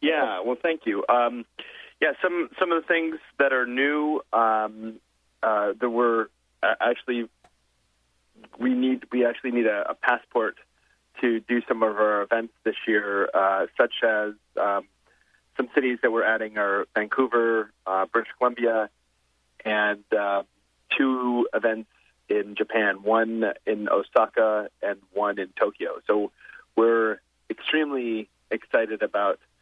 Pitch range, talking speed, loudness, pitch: 105-125 Hz, 140 wpm, -25 LUFS, 110 Hz